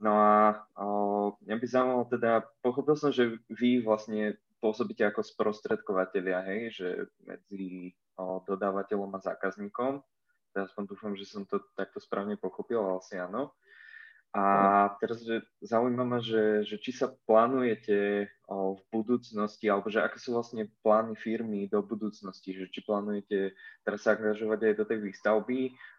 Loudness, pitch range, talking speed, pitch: -31 LUFS, 100-115 Hz, 150 wpm, 105 Hz